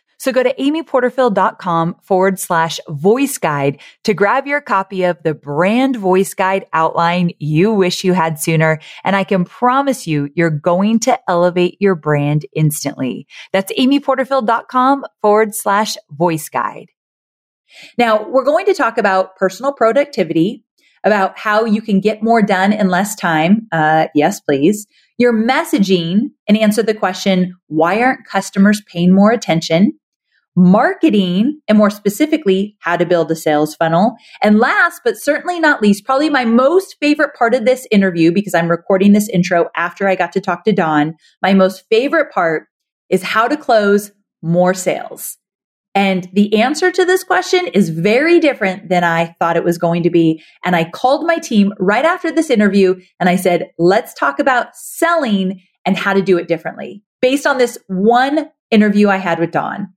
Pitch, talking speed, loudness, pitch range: 200 Hz, 170 wpm, -14 LUFS, 175-250 Hz